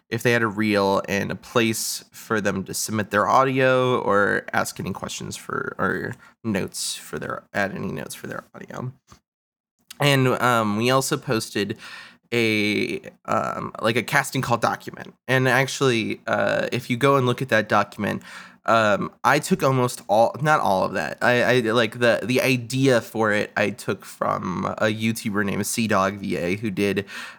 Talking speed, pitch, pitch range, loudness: 175 wpm, 120 Hz, 105-130 Hz, -22 LUFS